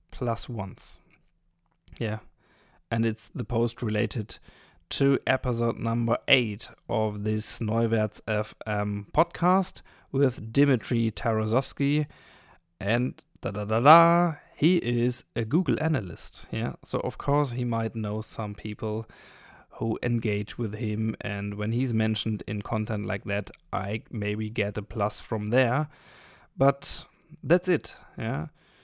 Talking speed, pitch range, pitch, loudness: 130 wpm, 105-130 Hz, 115 Hz, -27 LUFS